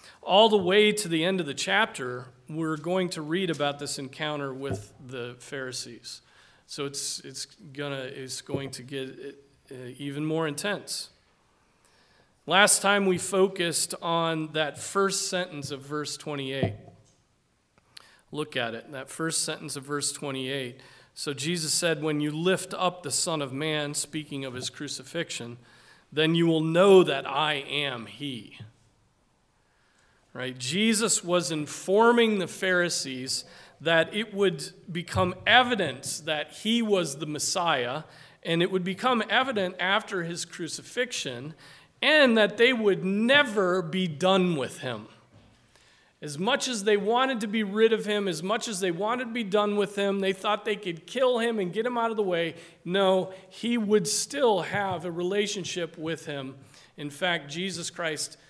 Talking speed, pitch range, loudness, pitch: 155 wpm, 140-195 Hz, -26 LUFS, 165 Hz